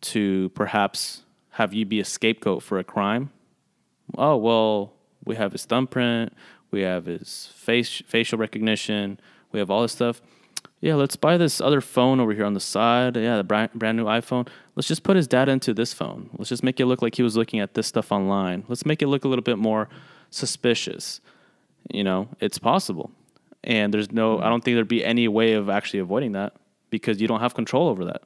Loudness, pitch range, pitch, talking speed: -23 LUFS, 105-125 Hz, 115 Hz, 210 wpm